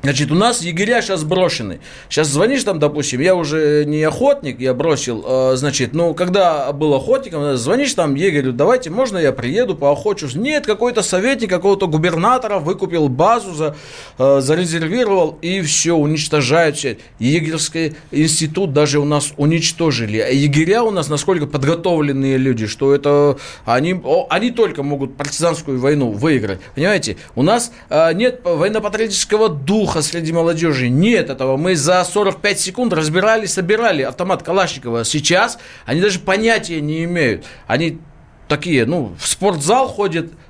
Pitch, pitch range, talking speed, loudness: 160 Hz, 145-190 Hz, 140 wpm, -16 LUFS